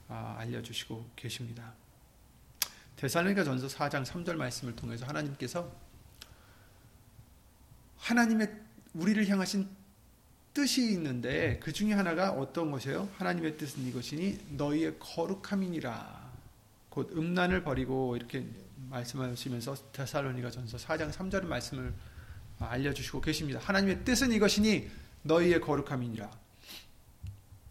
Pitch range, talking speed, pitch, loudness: 120-175 Hz, 290 characters per minute, 135 Hz, -33 LUFS